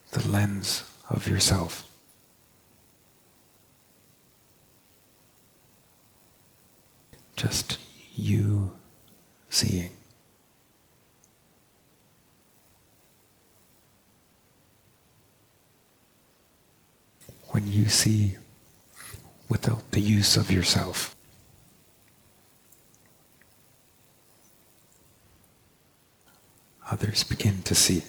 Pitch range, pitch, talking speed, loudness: 100-110 Hz, 105 Hz, 40 wpm, -26 LUFS